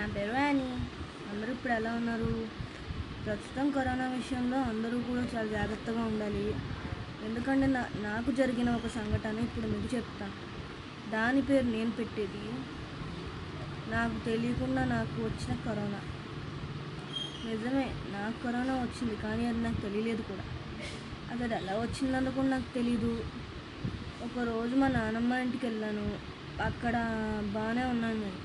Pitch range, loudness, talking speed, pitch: 210-250 Hz, -34 LUFS, 120 wpm, 230 Hz